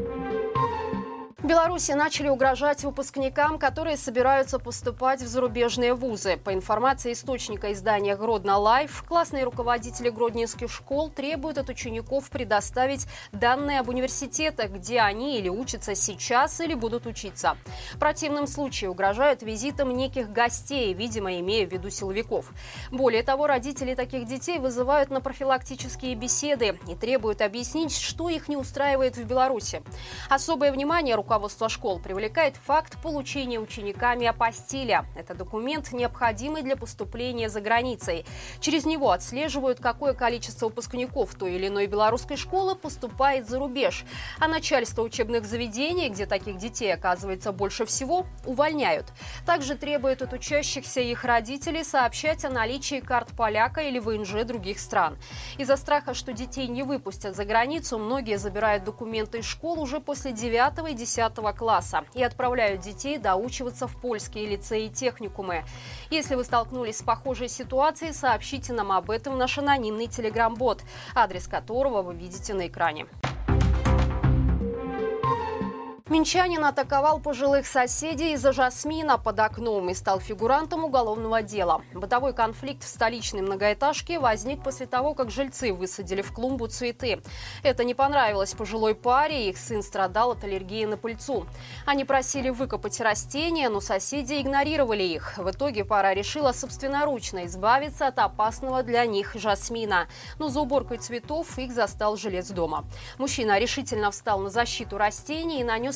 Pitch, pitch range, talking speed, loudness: 250 Hz, 215-280 Hz, 140 wpm, -26 LUFS